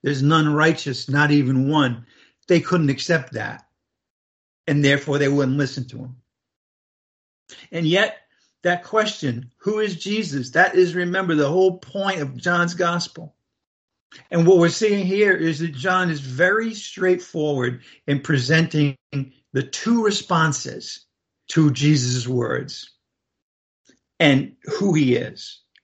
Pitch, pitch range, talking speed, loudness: 150 Hz, 135-180 Hz, 130 wpm, -20 LUFS